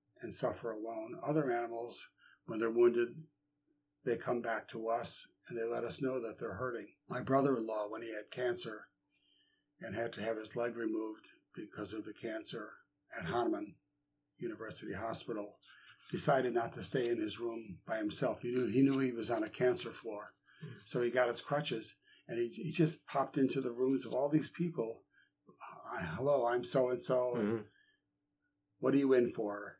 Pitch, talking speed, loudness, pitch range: 125 Hz, 180 wpm, -37 LUFS, 115-145 Hz